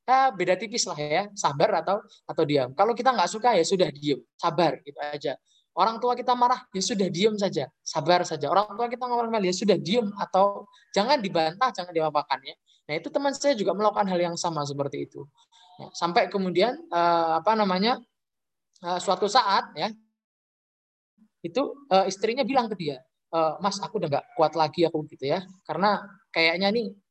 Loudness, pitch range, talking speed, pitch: -25 LUFS, 165-225 Hz, 180 wpm, 190 Hz